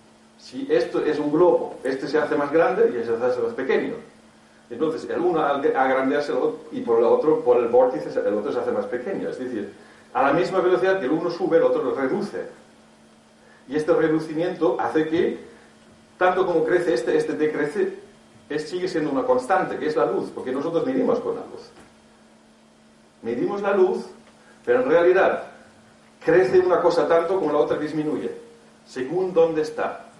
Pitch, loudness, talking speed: 180 Hz, -22 LUFS, 180 wpm